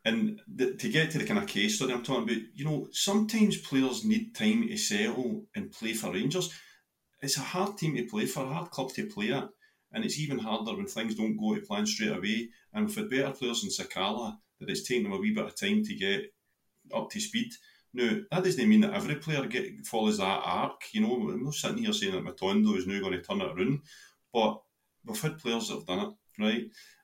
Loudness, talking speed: -31 LUFS, 225 wpm